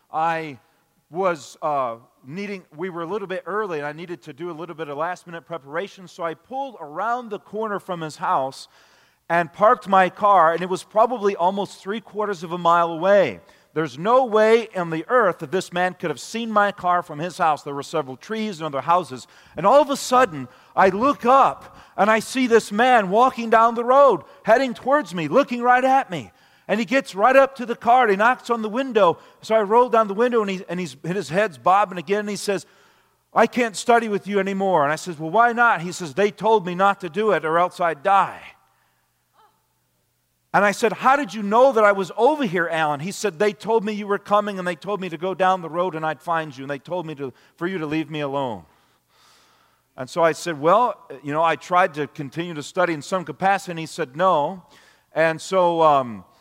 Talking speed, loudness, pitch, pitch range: 230 wpm, -21 LUFS, 185 Hz, 165-220 Hz